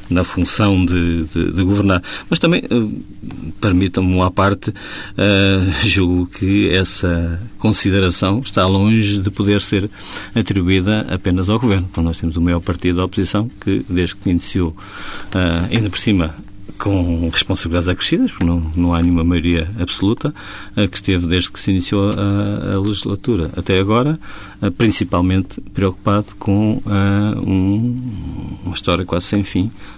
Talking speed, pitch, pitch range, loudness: 150 wpm, 95 Hz, 90-100 Hz, -17 LUFS